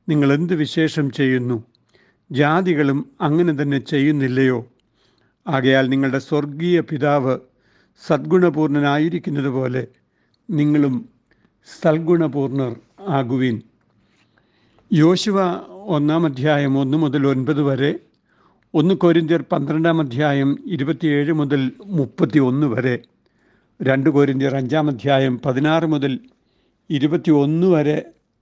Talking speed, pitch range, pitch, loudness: 85 wpm, 135-160 Hz, 145 Hz, -19 LUFS